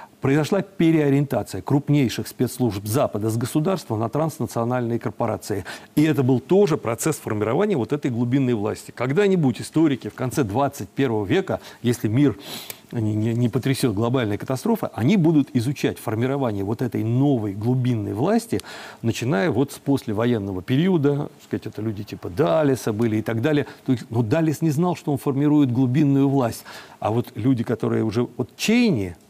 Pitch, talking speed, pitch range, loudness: 130 Hz, 145 wpm, 115-145 Hz, -22 LUFS